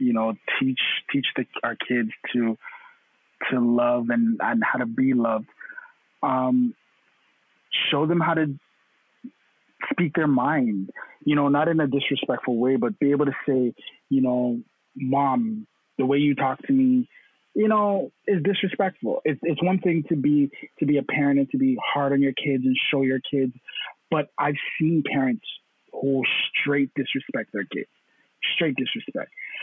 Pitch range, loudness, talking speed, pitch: 130-165 Hz, -24 LUFS, 165 wpm, 140 Hz